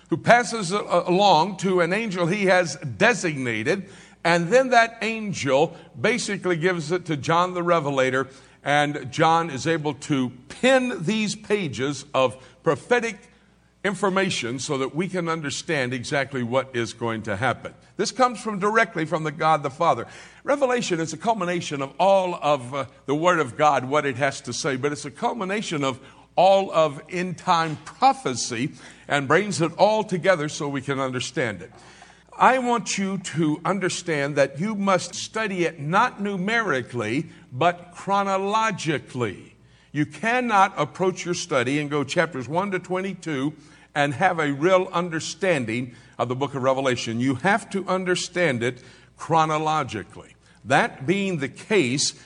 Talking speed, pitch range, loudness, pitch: 155 wpm, 140-190 Hz, -23 LUFS, 165 Hz